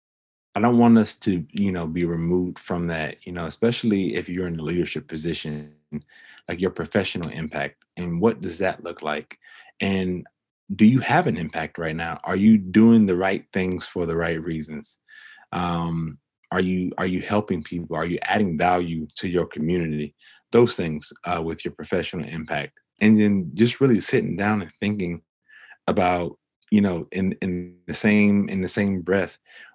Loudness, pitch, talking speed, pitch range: -23 LUFS, 90 Hz, 175 wpm, 85-105 Hz